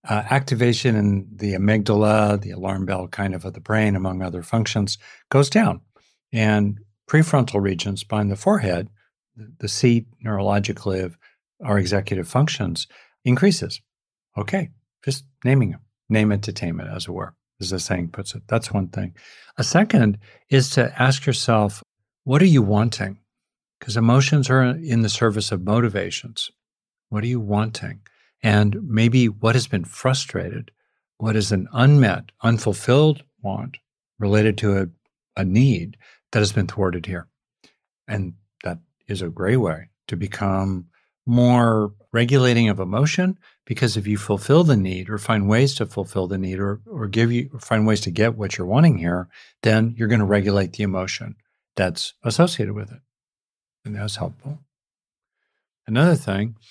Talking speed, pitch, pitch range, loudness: 160 wpm, 110 Hz, 100-125 Hz, -21 LUFS